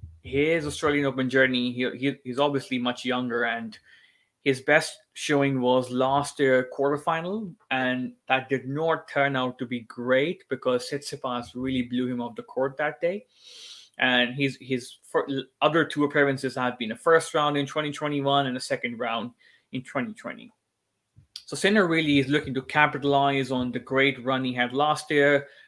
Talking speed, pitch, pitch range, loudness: 170 wpm, 135 Hz, 125-150 Hz, -25 LUFS